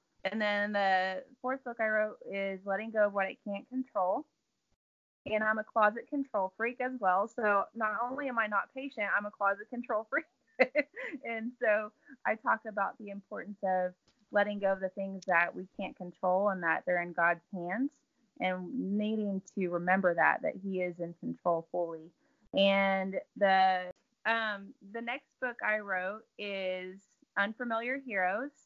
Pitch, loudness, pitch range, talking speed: 205 Hz, -33 LUFS, 190-235 Hz, 170 wpm